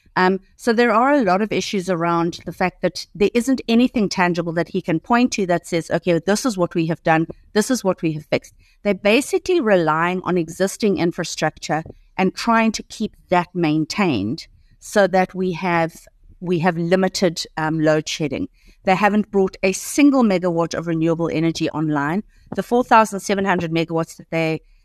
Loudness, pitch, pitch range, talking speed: -19 LUFS, 185 Hz, 165-205 Hz, 180 wpm